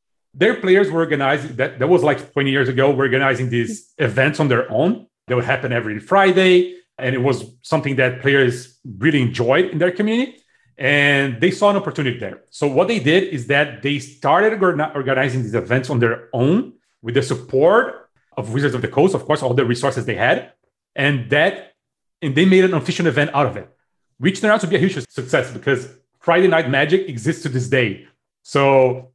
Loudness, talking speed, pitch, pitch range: -18 LUFS, 200 wpm, 140 Hz, 130-165 Hz